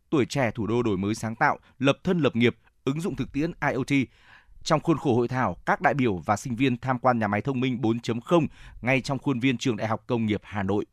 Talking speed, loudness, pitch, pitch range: 255 wpm, -26 LUFS, 125 Hz, 110-140 Hz